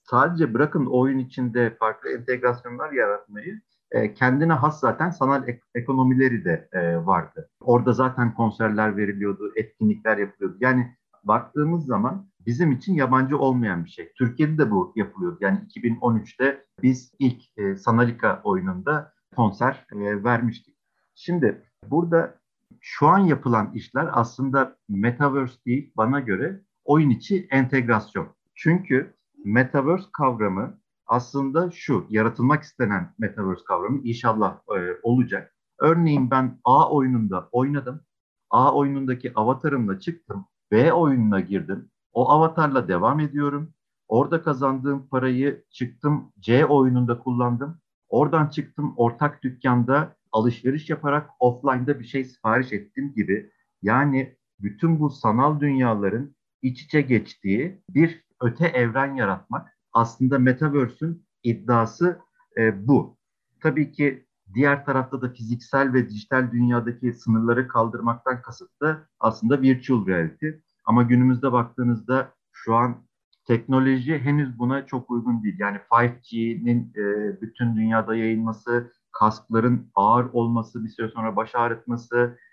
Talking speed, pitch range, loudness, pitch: 115 wpm, 115-145 Hz, -23 LUFS, 125 Hz